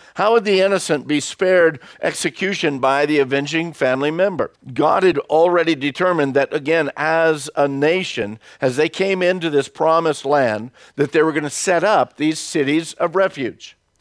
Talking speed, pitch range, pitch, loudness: 165 wpm, 145-180 Hz, 155 Hz, -18 LUFS